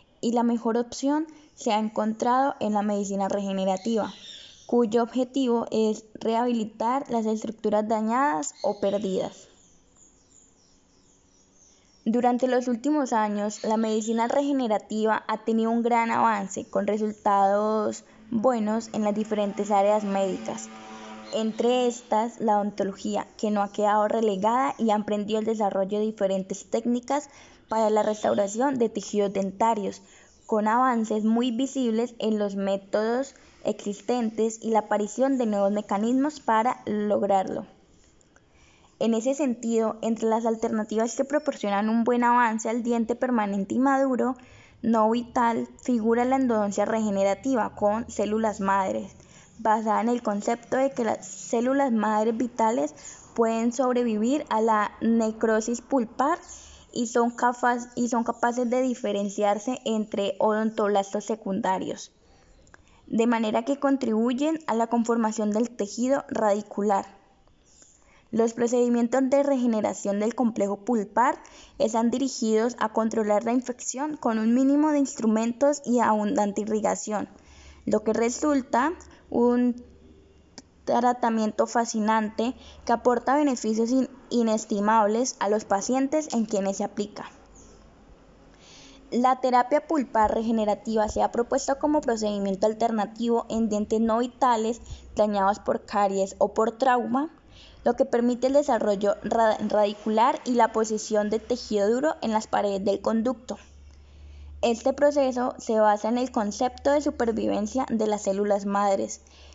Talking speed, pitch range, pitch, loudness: 125 wpm, 210-245 Hz, 225 Hz, -25 LUFS